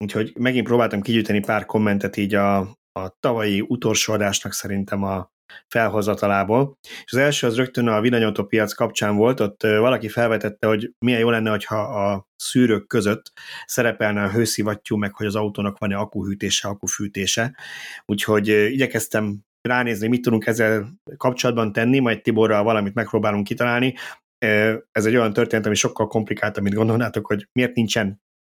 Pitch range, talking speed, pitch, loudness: 105-115 Hz, 150 wpm, 110 Hz, -21 LUFS